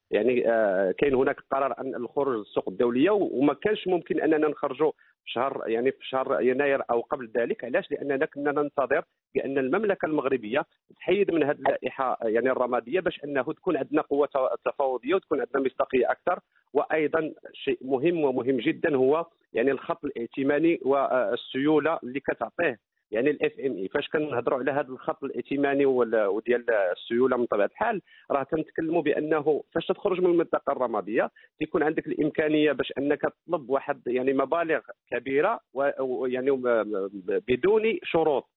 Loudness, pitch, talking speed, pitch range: -26 LUFS, 150 Hz, 140 wpm, 135-170 Hz